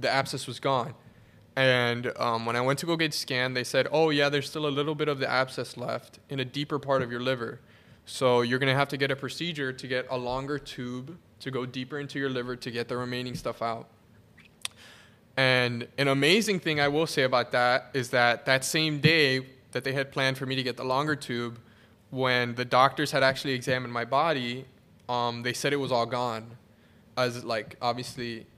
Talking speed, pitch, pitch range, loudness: 215 wpm, 130 Hz, 120-140 Hz, -27 LUFS